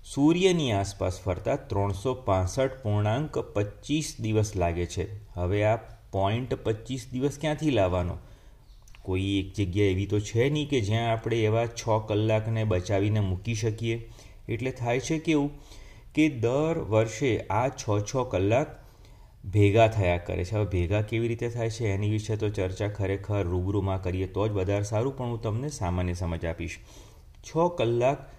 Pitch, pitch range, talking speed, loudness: 110 Hz, 100-120 Hz, 150 wpm, -28 LUFS